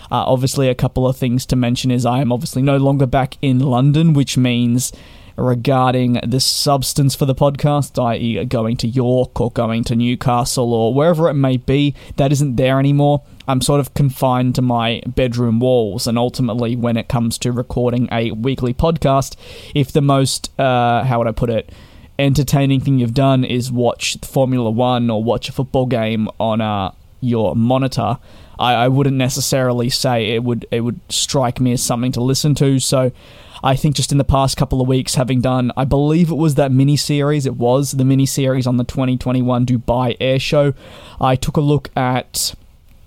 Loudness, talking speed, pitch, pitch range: -16 LUFS, 190 wpm, 130 Hz, 120-135 Hz